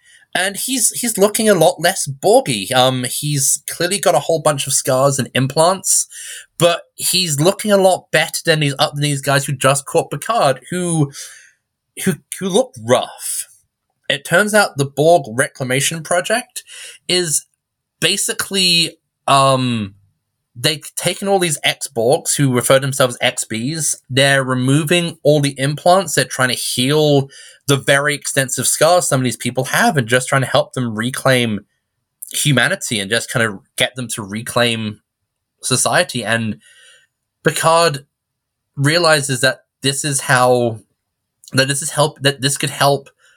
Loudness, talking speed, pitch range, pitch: -16 LUFS, 155 wpm, 130-170 Hz, 140 Hz